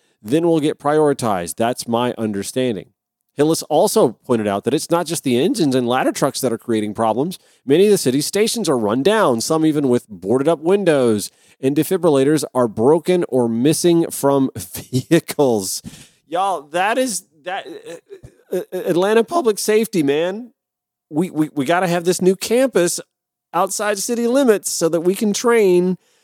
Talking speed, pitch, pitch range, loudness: 165 wpm, 165 Hz, 130-190 Hz, -18 LUFS